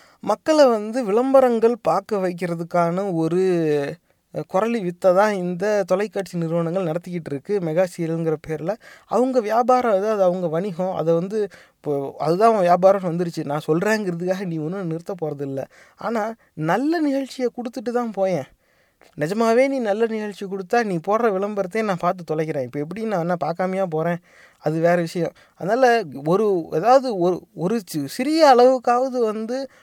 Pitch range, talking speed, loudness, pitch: 170-230 Hz, 135 wpm, -21 LUFS, 190 Hz